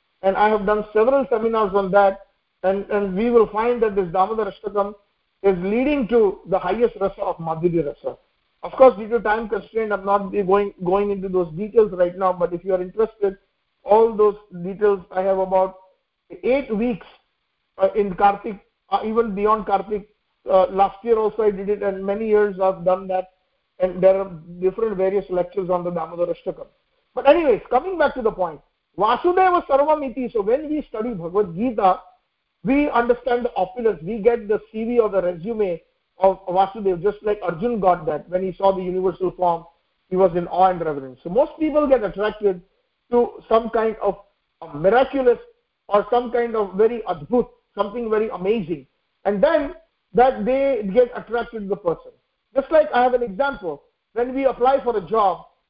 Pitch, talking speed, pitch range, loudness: 210 Hz, 180 wpm, 190-240 Hz, -20 LUFS